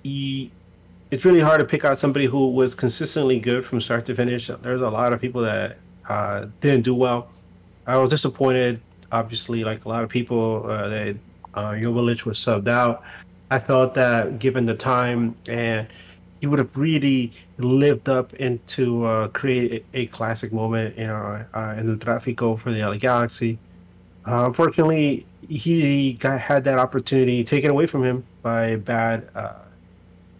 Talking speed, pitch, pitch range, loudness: 175 wpm, 120 Hz, 110-130 Hz, -22 LUFS